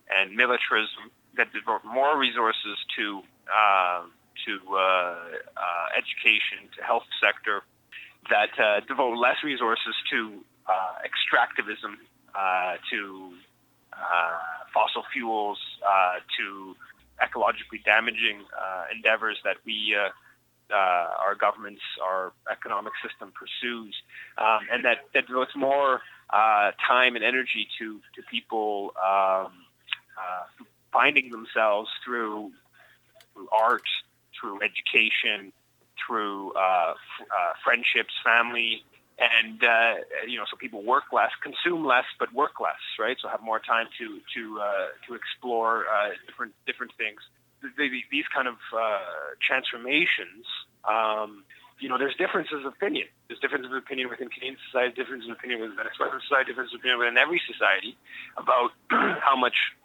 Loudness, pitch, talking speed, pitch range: -25 LUFS, 110 Hz, 135 wpm, 100-125 Hz